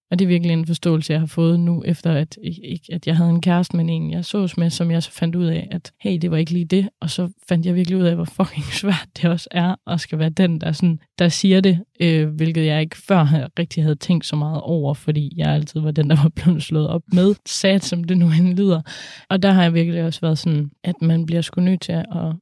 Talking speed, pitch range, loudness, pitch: 270 wpm, 160-180 Hz, -19 LUFS, 170 Hz